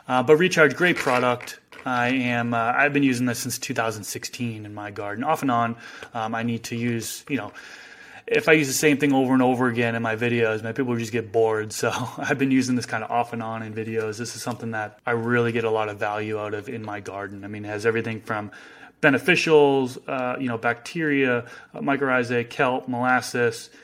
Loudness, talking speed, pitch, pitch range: -23 LUFS, 220 wpm, 120 Hz, 110-130 Hz